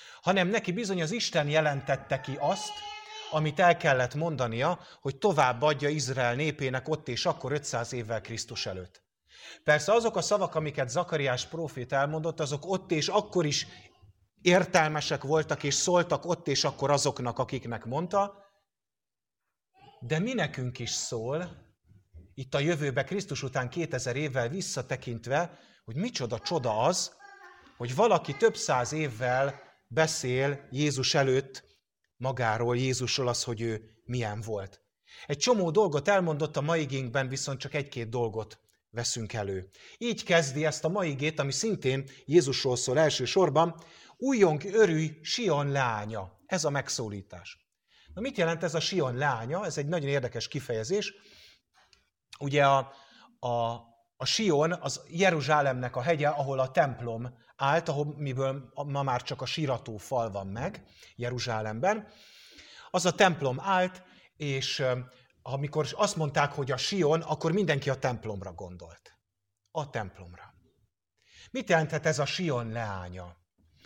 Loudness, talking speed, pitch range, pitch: -29 LUFS, 140 wpm, 125-170 Hz, 145 Hz